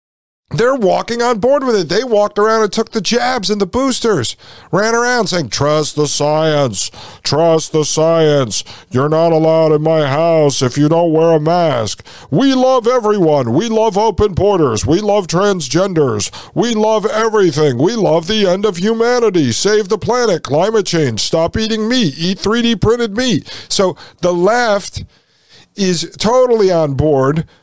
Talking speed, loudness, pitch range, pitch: 165 wpm, -13 LUFS, 150-220 Hz, 175 Hz